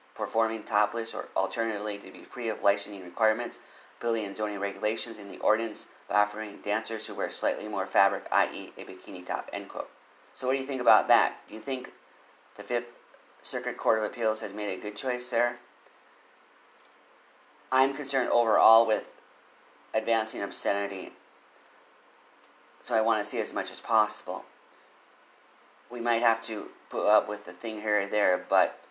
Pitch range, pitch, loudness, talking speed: 105-120 Hz, 110 Hz, -28 LUFS, 170 wpm